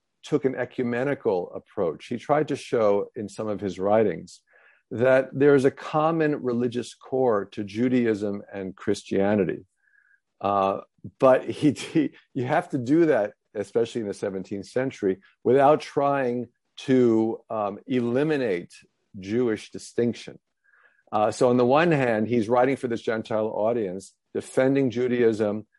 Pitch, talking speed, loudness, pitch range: 120 Hz, 135 wpm, -24 LUFS, 105-130 Hz